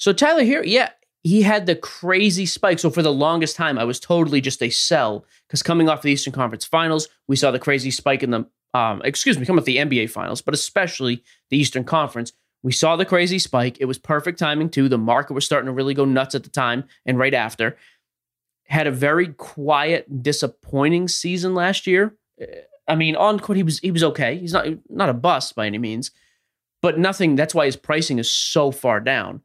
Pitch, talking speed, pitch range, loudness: 150 Hz, 215 wpm, 130-175 Hz, -20 LUFS